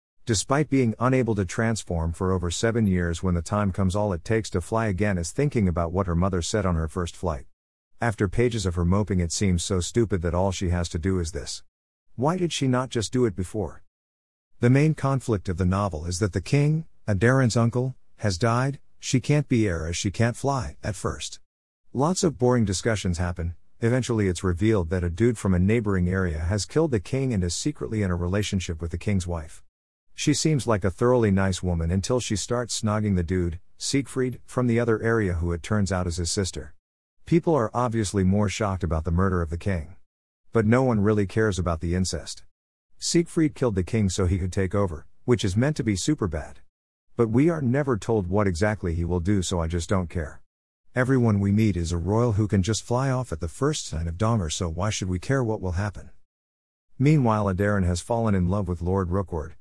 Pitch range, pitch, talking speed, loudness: 90-115 Hz, 100 Hz, 220 wpm, -25 LUFS